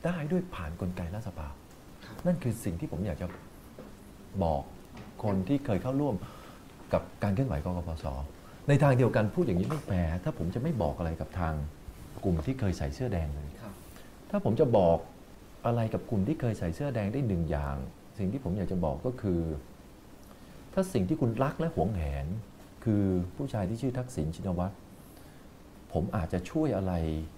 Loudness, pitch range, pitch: -32 LUFS, 85-120 Hz, 95 Hz